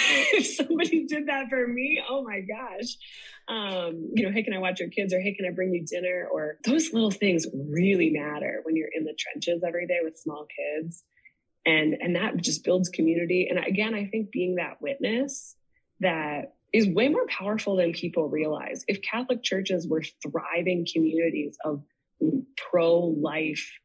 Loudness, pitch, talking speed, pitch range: -27 LUFS, 180 Hz, 175 wpm, 165-225 Hz